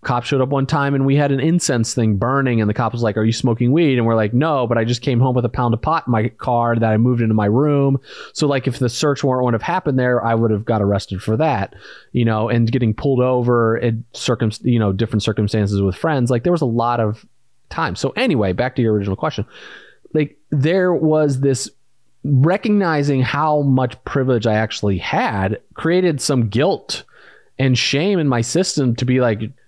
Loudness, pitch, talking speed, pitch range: -18 LUFS, 125 Hz, 225 wpm, 115-140 Hz